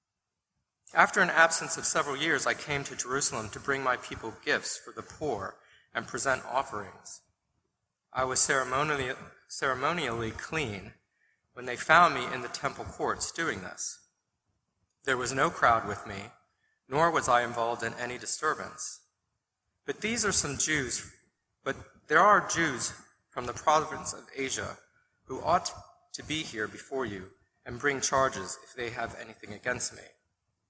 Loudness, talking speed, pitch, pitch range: -28 LUFS, 155 wpm, 125 Hz, 115-145 Hz